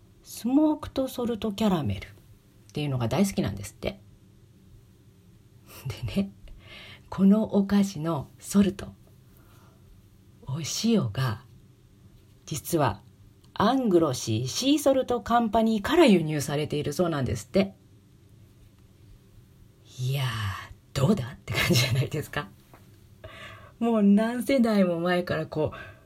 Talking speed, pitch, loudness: 240 characters per minute, 130 Hz, -26 LUFS